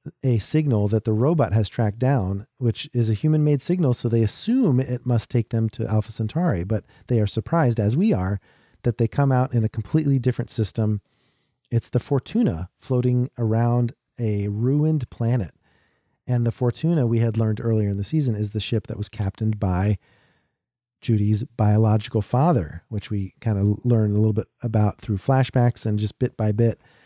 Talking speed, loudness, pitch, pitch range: 185 wpm, -23 LUFS, 115 Hz, 110-125 Hz